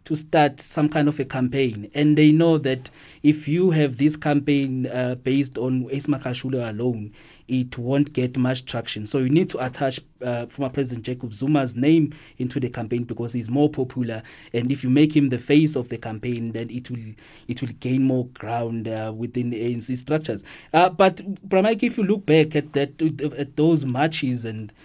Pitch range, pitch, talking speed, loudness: 120-150 Hz, 130 Hz, 195 wpm, -22 LUFS